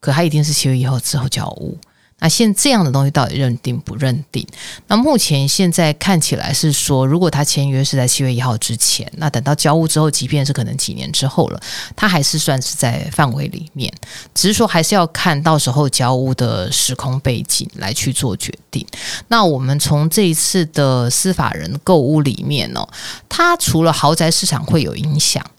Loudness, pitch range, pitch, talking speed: -15 LUFS, 130-165 Hz, 150 Hz, 300 characters per minute